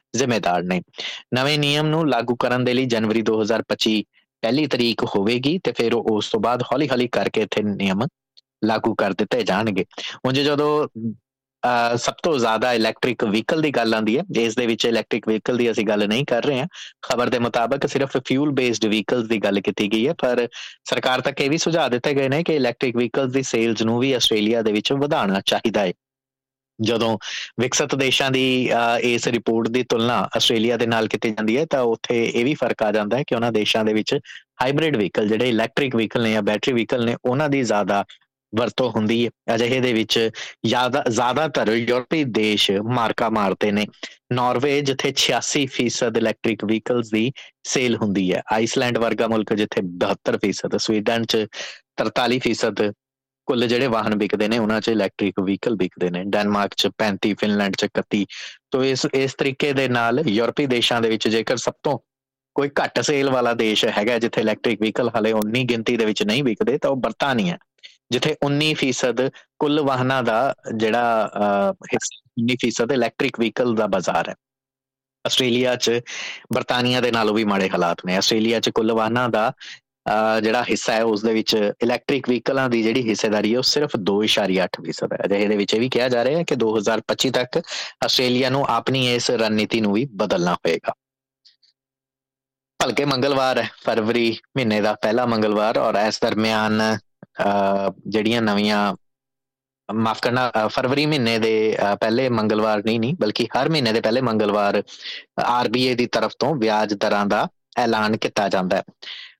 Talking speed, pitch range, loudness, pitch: 165 wpm, 110-130 Hz, -20 LUFS, 115 Hz